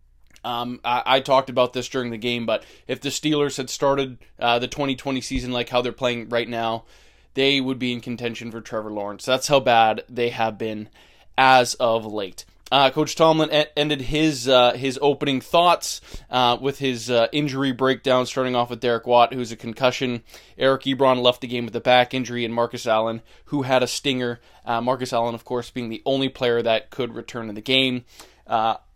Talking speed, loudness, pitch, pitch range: 205 wpm, -22 LUFS, 125 Hz, 120-135 Hz